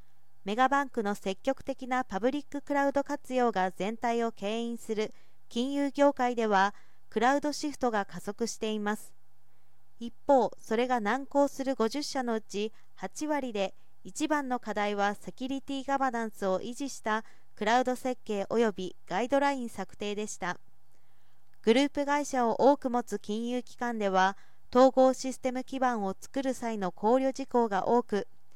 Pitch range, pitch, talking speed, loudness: 200-265 Hz, 235 Hz, 305 characters per minute, -30 LUFS